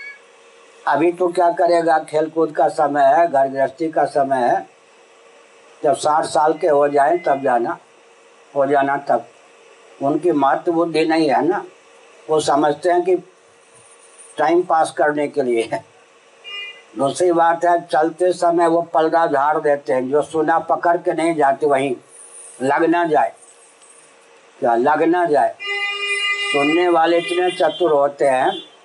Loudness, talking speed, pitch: -17 LUFS, 145 wpm, 170 Hz